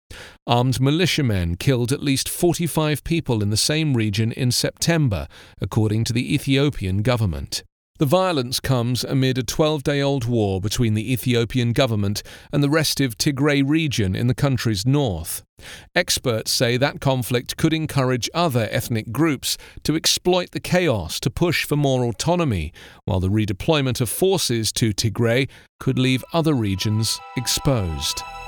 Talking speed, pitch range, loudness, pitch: 145 wpm, 110-145 Hz, -21 LUFS, 125 Hz